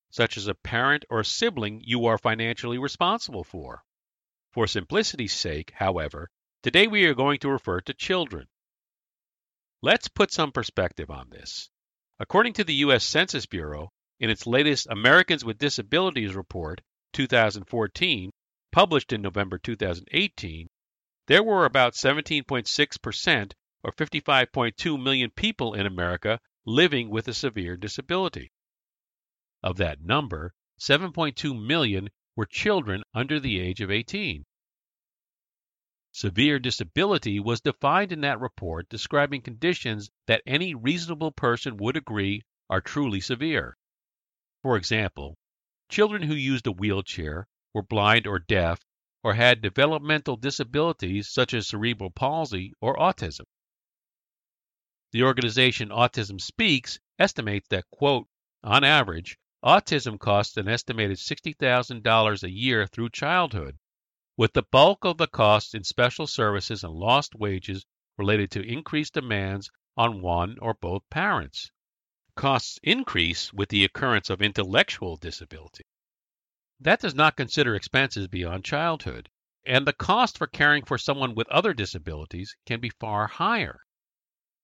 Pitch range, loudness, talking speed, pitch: 100-140 Hz, -24 LUFS, 130 wpm, 115 Hz